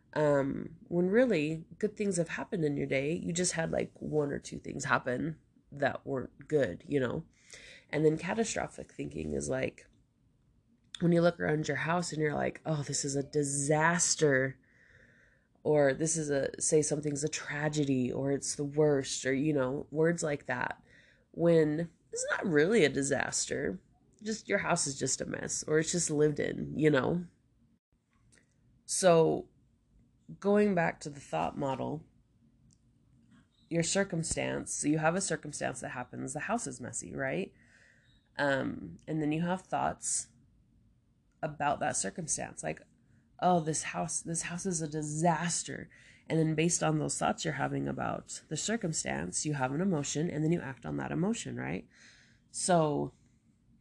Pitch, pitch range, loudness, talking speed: 150 Hz, 135-170 Hz, -32 LUFS, 160 wpm